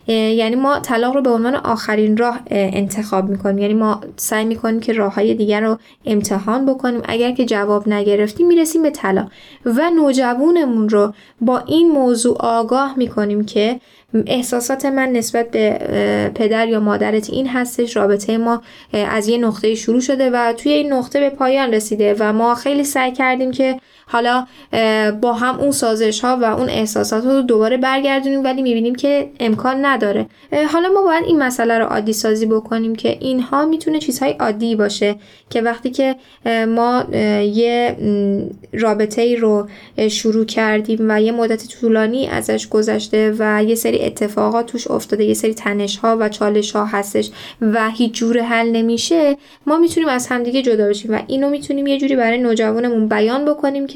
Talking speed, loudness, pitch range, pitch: 165 wpm, -16 LUFS, 215-260 Hz, 230 Hz